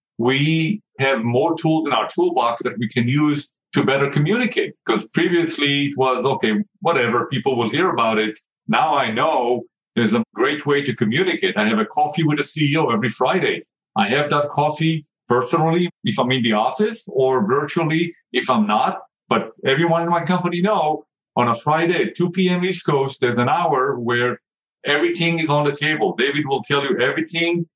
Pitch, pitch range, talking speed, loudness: 150 Hz, 135-175 Hz, 185 wpm, -19 LUFS